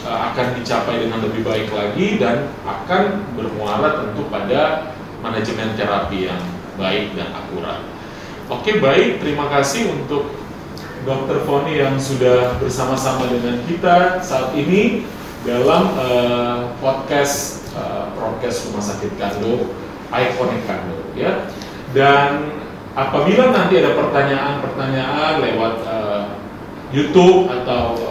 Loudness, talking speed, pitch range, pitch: -18 LUFS, 110 wpm, 115-145 Hz, 130 Hz